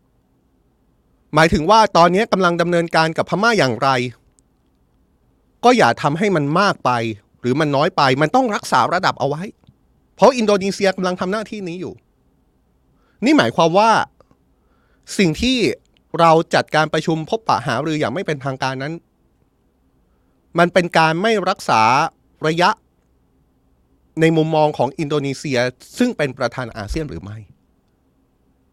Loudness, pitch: -17 LUFS, 145 Hz